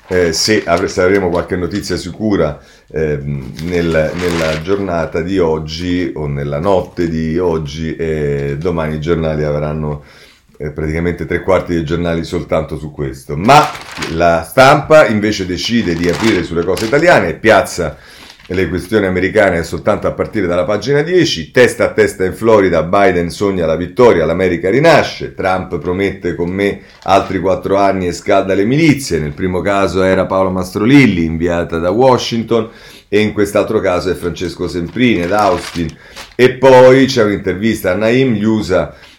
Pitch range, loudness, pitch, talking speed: 80-100 Hz, -13 LUFS, 90 Hz, 155 wpm